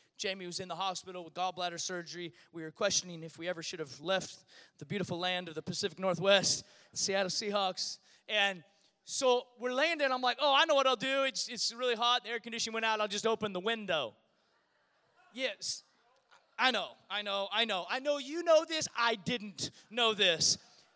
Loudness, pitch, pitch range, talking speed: -32 LUFS, 200 Hz, 180-240 Hz, 195 wpm